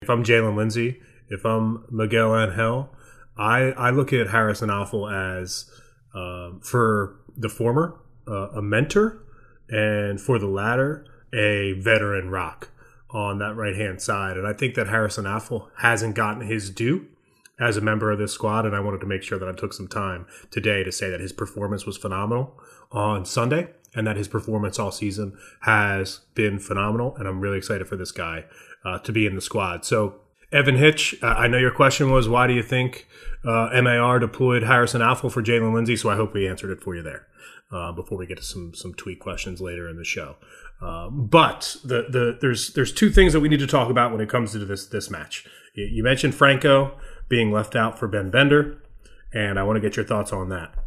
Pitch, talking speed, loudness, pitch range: 110 Hz, 205 wpm, -22 LUFS, 100-125 Hz